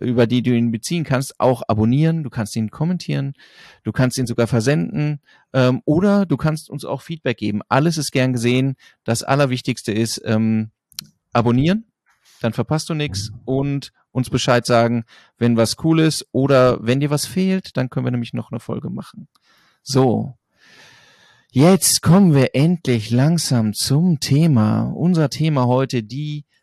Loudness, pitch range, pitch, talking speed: -18 LUFS, 120-150 Hz, 130 Hz, 160 wpm